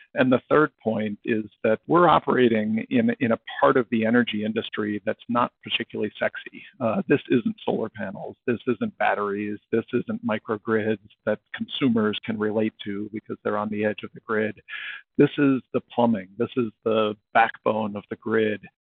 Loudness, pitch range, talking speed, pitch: -24 LUFS, 105-125 Hz, 175 wpm, 110 Hz